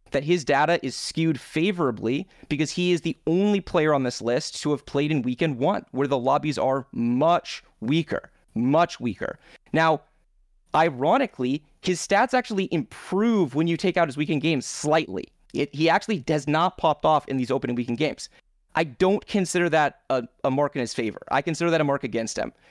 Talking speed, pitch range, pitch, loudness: 190 wpm, 135-175 Hz, 155 Hz, -24 LUFS